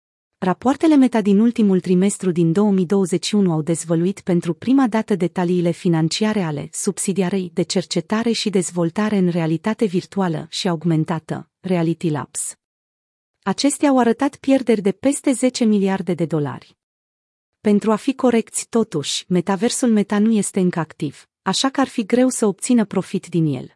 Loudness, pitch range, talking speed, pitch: -19 LUFS, 170-220 Hz, 145 wpm, 190 Hz